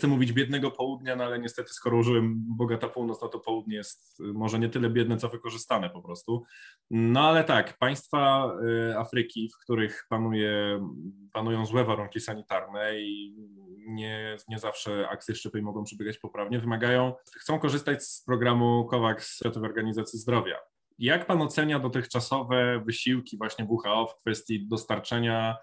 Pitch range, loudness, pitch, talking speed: 110-125 Hz, -28 LUFS, 115 Hz, 145 wpm